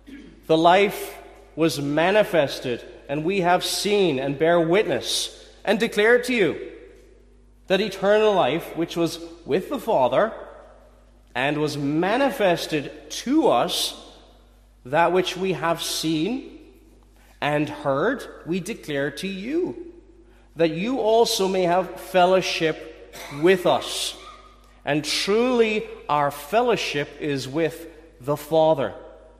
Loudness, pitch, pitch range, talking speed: -22 LUFS, 175 Hz, 150-215 Hz, 110 wpm